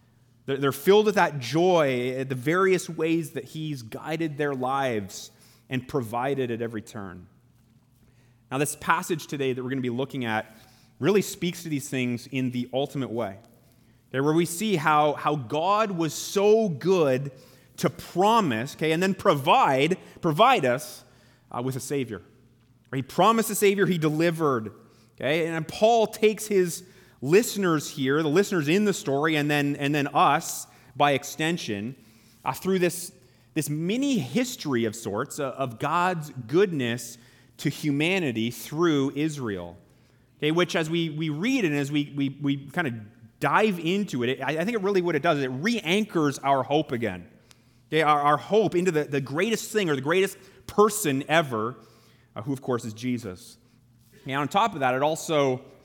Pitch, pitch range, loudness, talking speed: 145 Hz, 125-170 Hz, -25 LUFS, 170 wpm